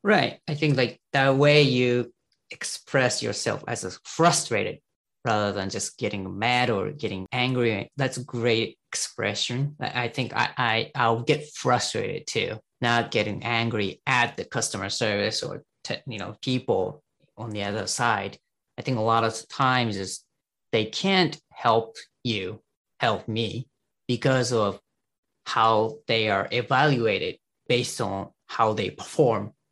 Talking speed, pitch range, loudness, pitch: 145 wpm, 110-130 Hz, -25 LUFS, 120 Hz